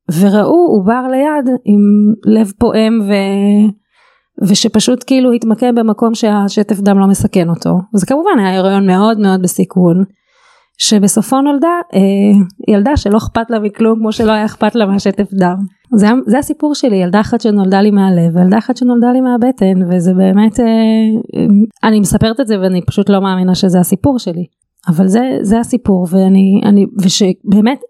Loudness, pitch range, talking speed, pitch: -11 LUFS, 195-235 Hz, 160 wpm, 210 Hz